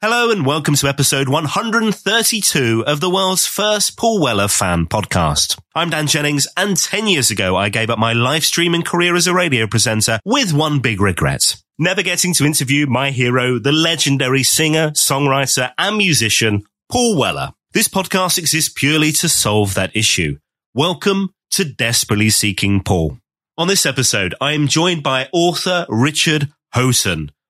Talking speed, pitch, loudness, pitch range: 160 wpm, 145 Hz, -15 LUFS, 115-175 Hz